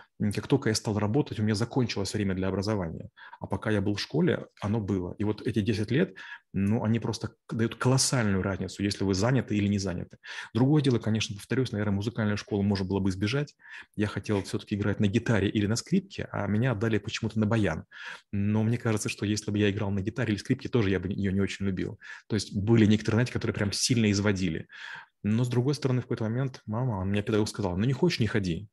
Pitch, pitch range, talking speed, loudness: 105 Hz, 100-115 Hz, 225 wpm, -28 LUFS